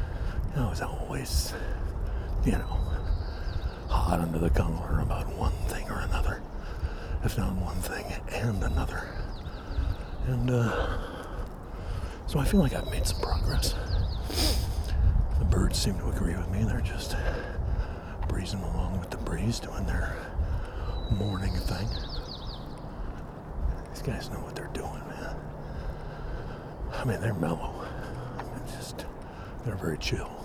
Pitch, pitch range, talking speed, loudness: 90 Hz, 80-95 Hz, 130 wpm, -32 LUFS